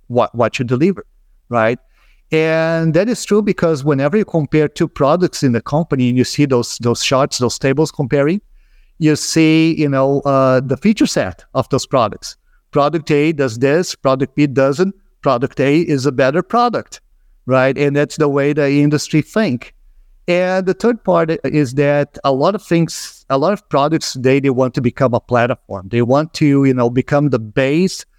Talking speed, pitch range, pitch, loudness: 185 wpm, 135-165 Hz, 145 Hz, -15 LUFS